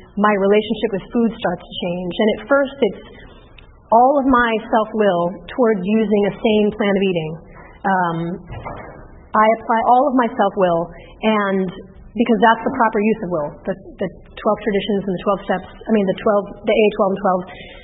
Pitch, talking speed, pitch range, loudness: 205 Hz, 190 wpm, 185-225 Hz, -18 LUFS